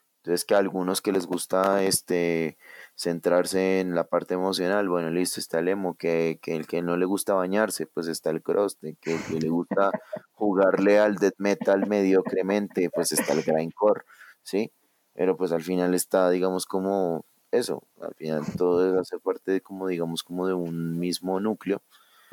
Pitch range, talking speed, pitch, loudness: 85-95 Hz, 180 wpm, 95 Hz, -26 LUFS